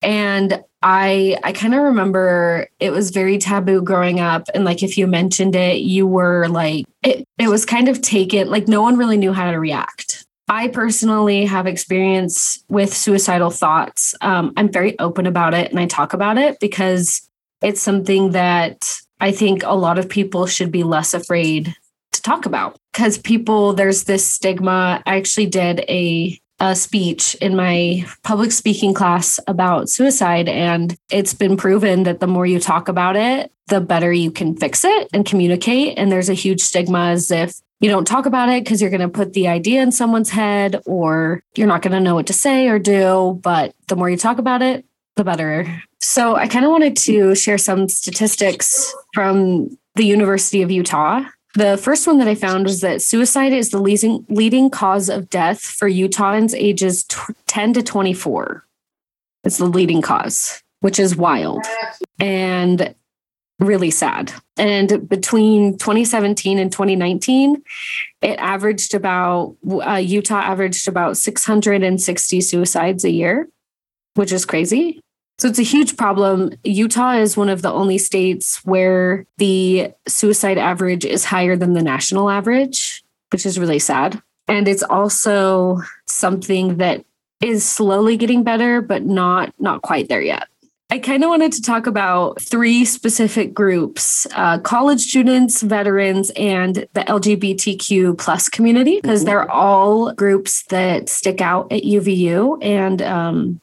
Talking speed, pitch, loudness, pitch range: 170 wpm, 195 Hz, -16 LUFS, 185-215 Hz